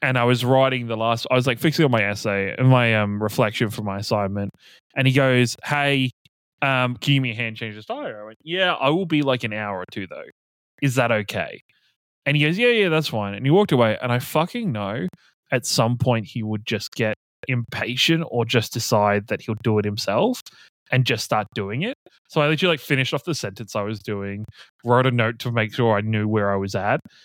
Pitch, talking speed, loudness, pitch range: 120 Hz, 240 wpm, -21 LUFS, 110-140 Hz